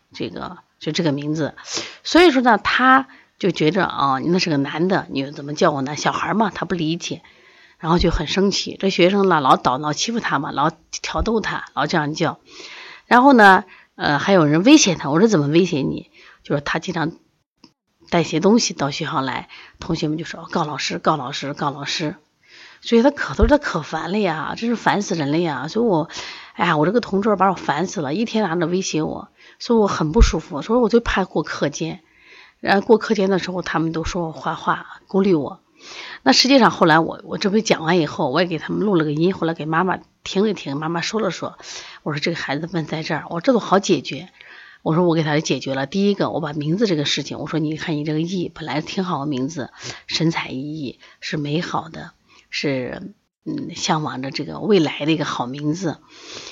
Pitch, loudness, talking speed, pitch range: 165 Hz, -19 LUFS, 305 characters per minute, 155-195 Hz